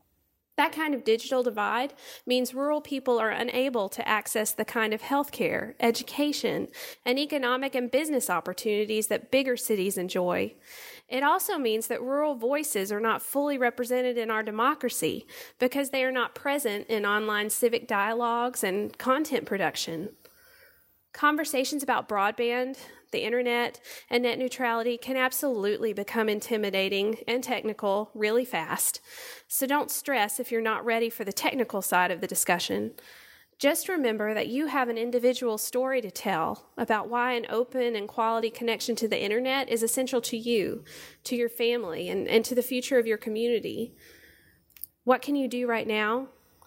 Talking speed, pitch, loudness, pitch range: 155 wpm, 240 Hz, -28 LUFS, 220-260 Hz